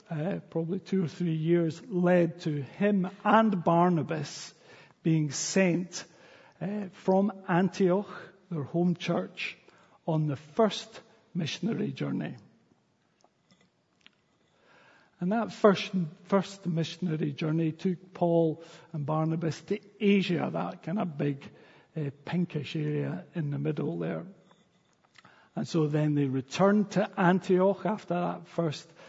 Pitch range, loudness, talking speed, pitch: 160-195 Hz, -29 LUFS, 120 wpm, 175 Hz